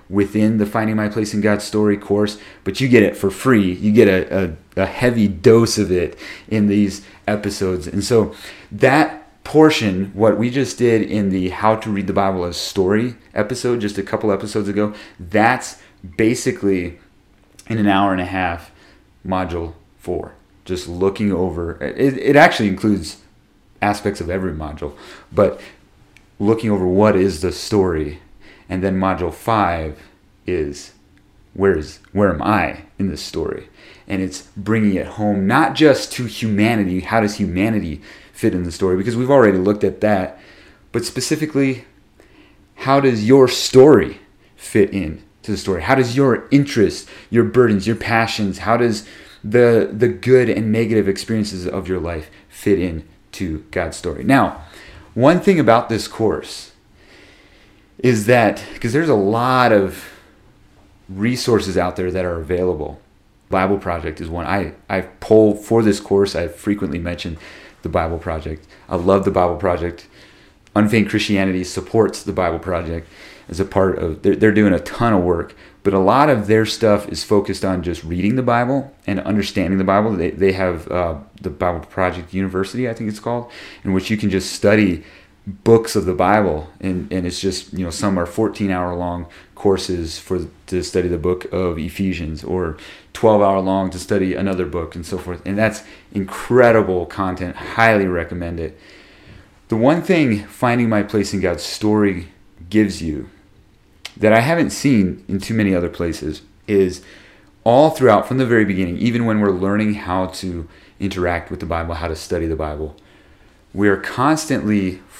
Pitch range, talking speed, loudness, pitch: 90-110 Hz, 170 wpm, -18 LUFS, 100 Hz